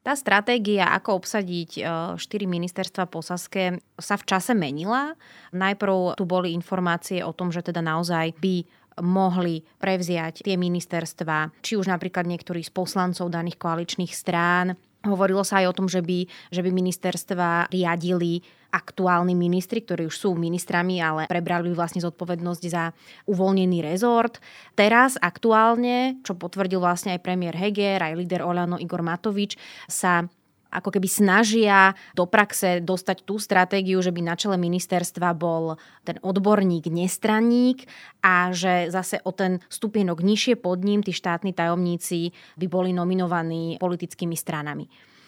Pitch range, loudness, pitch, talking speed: 175-195 Hz, -24 LUFS, 180 Hz, 140 wpm